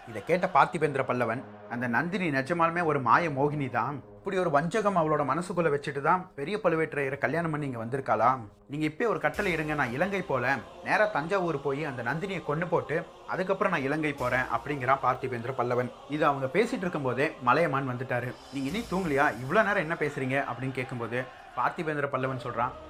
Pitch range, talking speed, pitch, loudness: 130-170 Hz, 145 wpm, 145 Hz, -28 LUFS